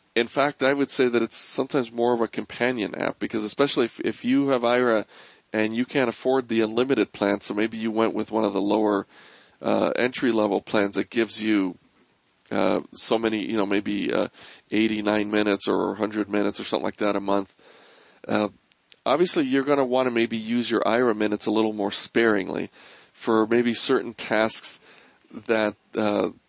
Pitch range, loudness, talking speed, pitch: 105-120 Hz, -24 LUFS, 190 wpm, 110 Hz